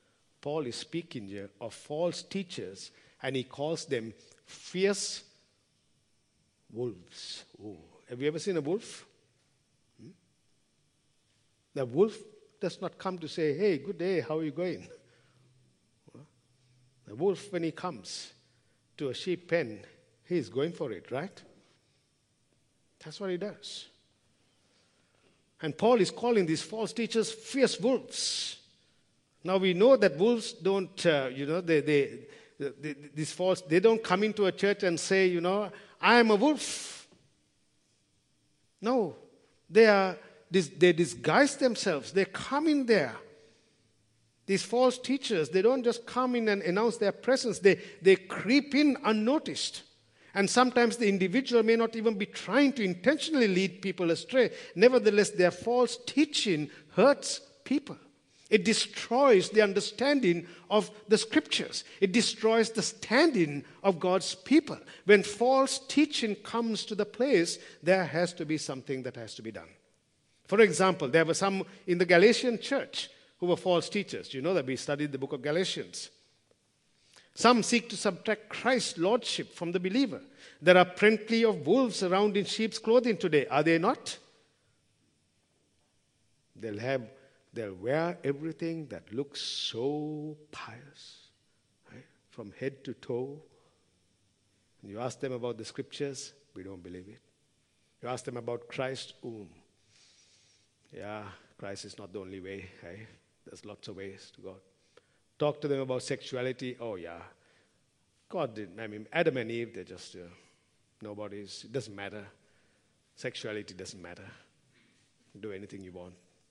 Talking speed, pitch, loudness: 150 wpm, 170 Hz, -29 LUFS